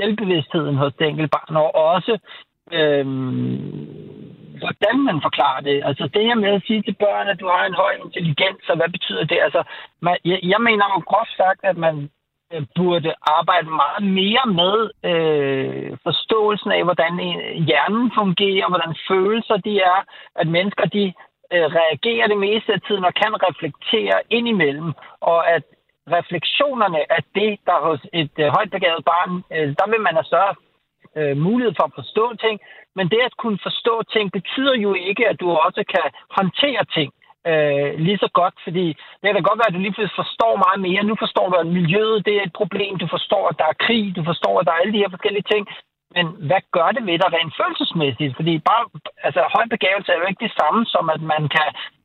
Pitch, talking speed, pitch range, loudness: 185 Hz, 195 wpm, 160-210 Hz, -19 LUFS